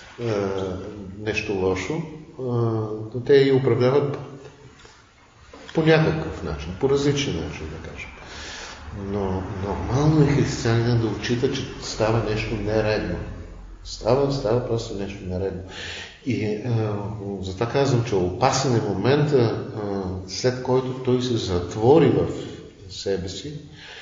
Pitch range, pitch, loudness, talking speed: 95-130 Hz, 110 Hz, -23 LUFS, 110 wpm